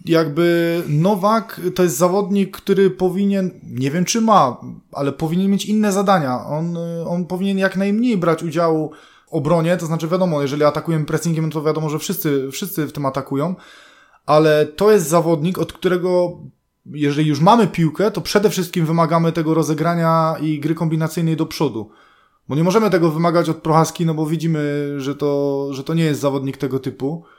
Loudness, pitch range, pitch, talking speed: -18 LUFS, 150-185 Hz, 165 Hz, 175 wpm